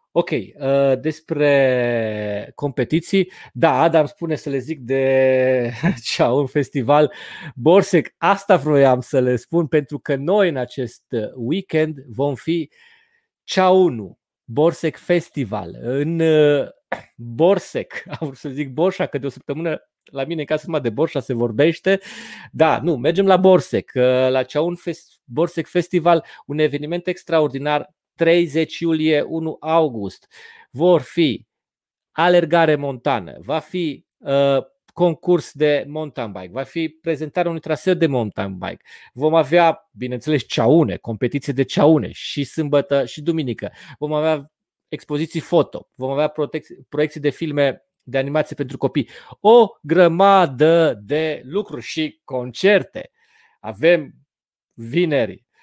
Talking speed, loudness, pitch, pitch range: 125 wpm, -19 LUFS, 155 Hz, 135-170 Hz